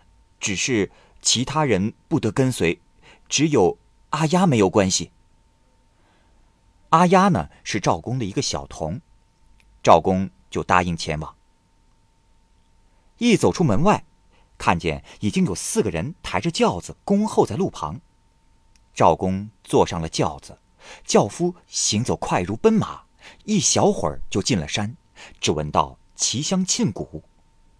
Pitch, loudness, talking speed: 100 Hz, -21 LUFS, 190 characters per minute